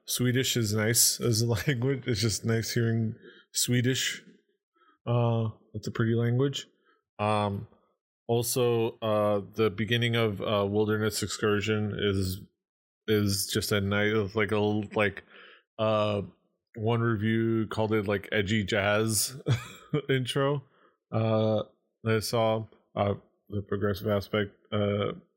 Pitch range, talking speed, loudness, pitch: 105-120 Hz, 125 wpm, -28 LUFS, 110 Hz